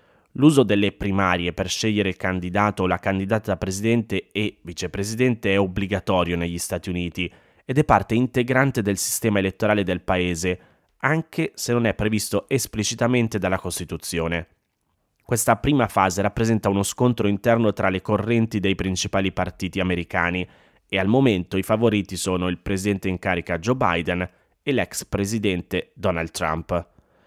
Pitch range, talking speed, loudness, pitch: 90-110 Hz, 145 wpm, -22 LUFS, 100 Hz